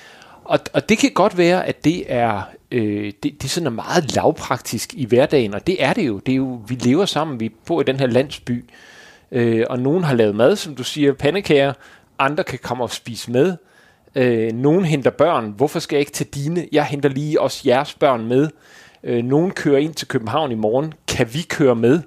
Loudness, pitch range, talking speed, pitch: -19 LUFS, 120-150 Hz, 220 wpm, 135 Hz